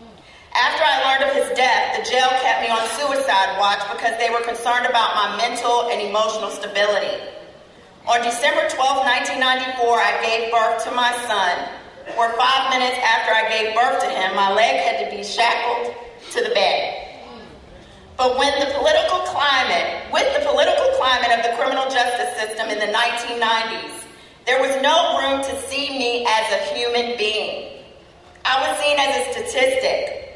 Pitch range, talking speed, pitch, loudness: 230-275 Hz, 170 wpm, 245 Hz, -19 LUFS